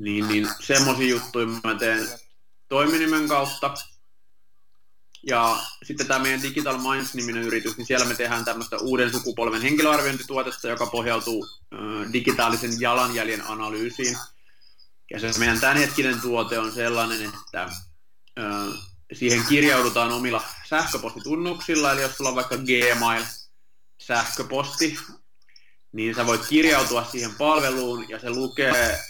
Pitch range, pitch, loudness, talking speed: 115-135 Hz, 120 Hz, -23 LUFS, 120 wpm